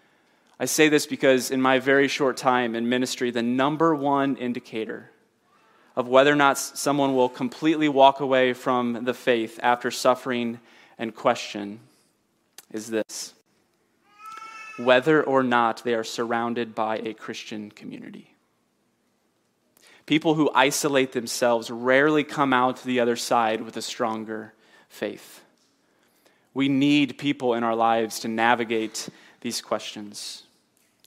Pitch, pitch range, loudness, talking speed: 125 Hz, 115-140 Hz, -23 LUFS, 130 wpm